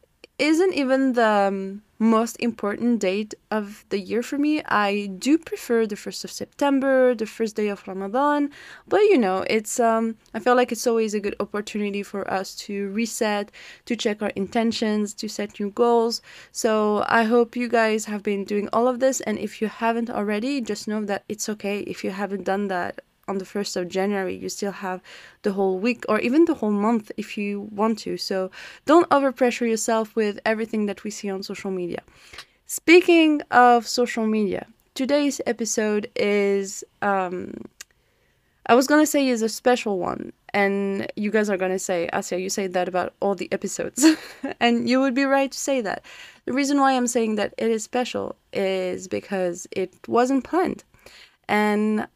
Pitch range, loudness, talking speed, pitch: 200-245 Hz, -23 LUFS, 180 wpm, 215 Hz